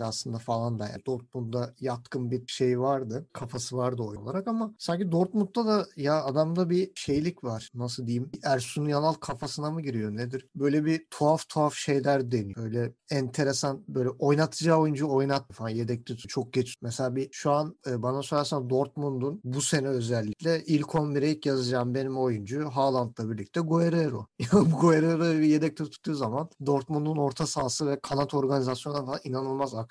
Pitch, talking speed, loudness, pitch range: 140 Hz, 165 wpm, -28 LUFS, 125-155 Hz